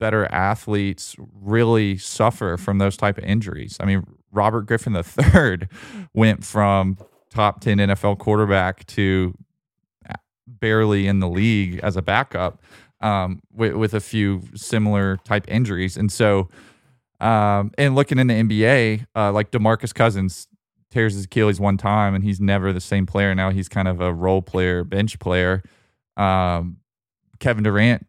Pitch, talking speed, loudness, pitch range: 100 Hz, 150 wpm, -20 LUFS, 95-110 Hz